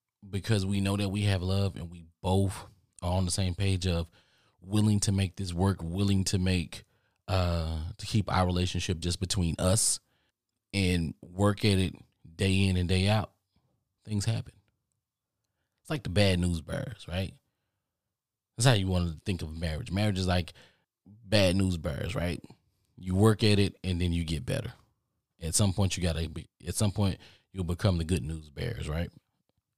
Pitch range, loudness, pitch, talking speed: 90-105 Hz, -29 LUFS, 95 Hz, 180 wpm